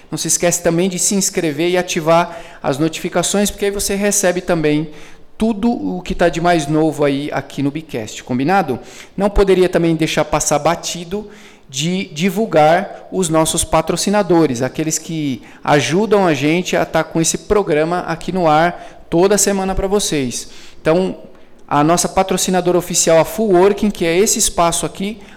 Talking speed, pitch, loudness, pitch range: 165 wpm, 175 Hz, -16 LUFS, 160-195 Hz